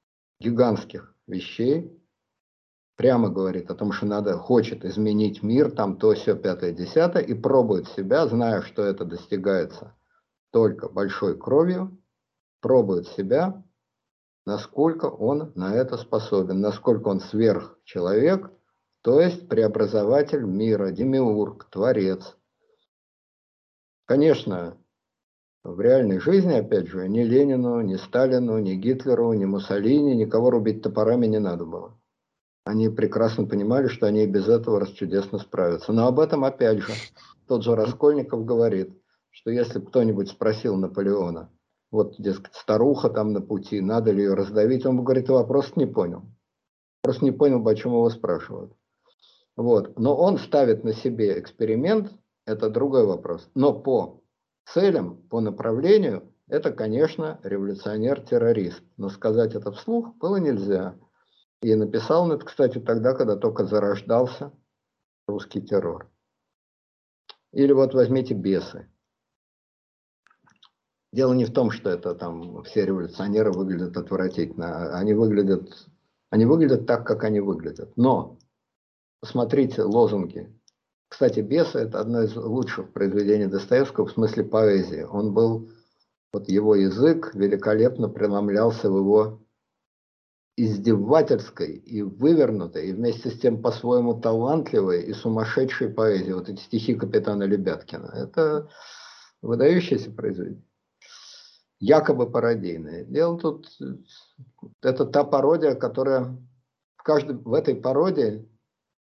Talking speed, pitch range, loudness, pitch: 125 wpm, 100-130 Hz, -23 LUFS, 110 Hz